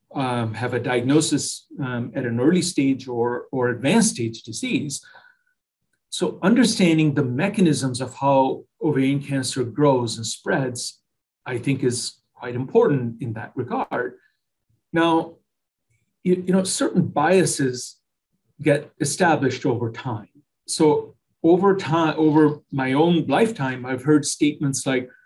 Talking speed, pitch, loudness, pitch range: 130 wpm, 140 Hz, -21 LUFS, 125-160 Hz